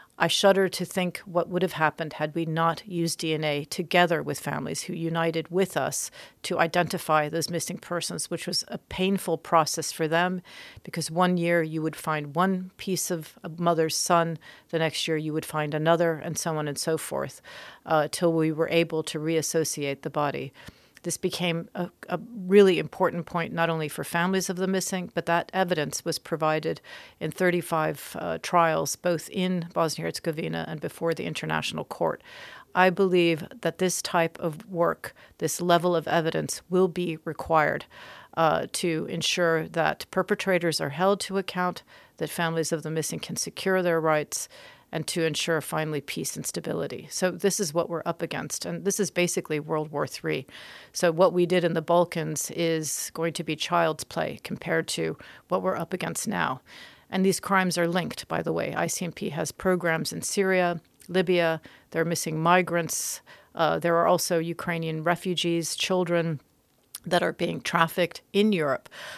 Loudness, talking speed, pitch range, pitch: -26 LUFS, 175 wpm, 160-180 Hz, 170 Hz